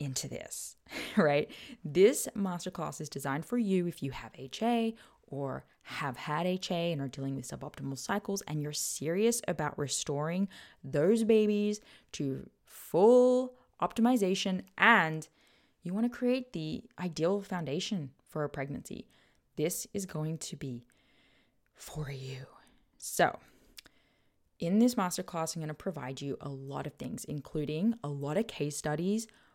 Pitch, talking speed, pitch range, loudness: 170 Hz, 140 wpm, 145-205 Hz, -32 LUFS